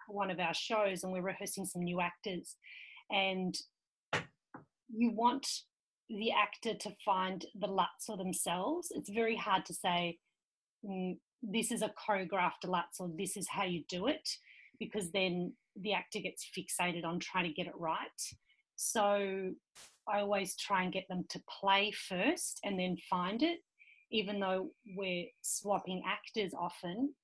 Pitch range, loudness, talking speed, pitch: 180-215 Hz, -37 LUFS, 155 wpm, 195 Hz